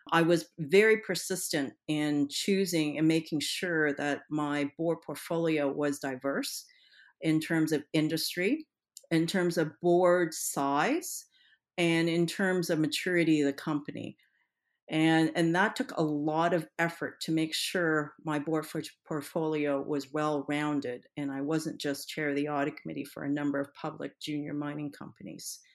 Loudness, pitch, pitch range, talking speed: -30 LUFS, 155 Hz, 145-170 Hz, 160 wpm